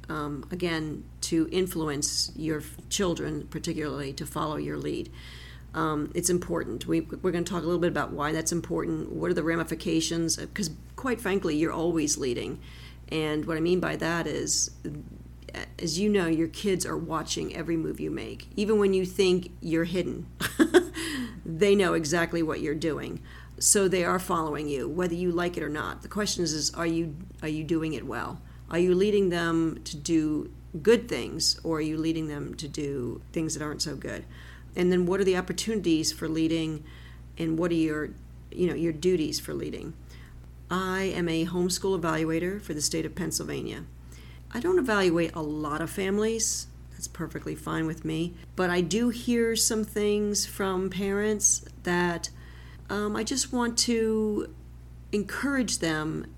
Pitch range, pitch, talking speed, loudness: 150-185 Hz, 165 Hz, 175 wpm, -28 LUFS